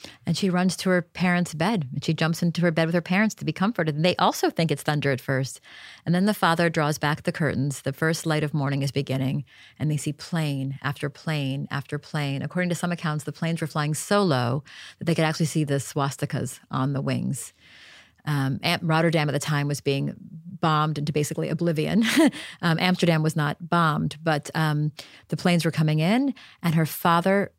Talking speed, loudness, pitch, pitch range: 210 wpm, -25 LUFS, 155 Hz, 145-175 Hz